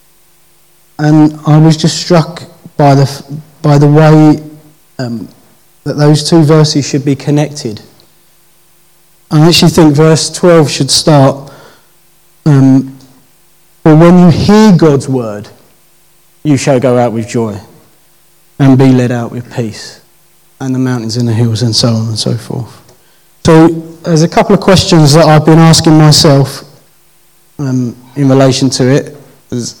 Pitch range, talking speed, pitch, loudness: 135-170 Hz, 145 wpm, 150 Hz, -7 LUFS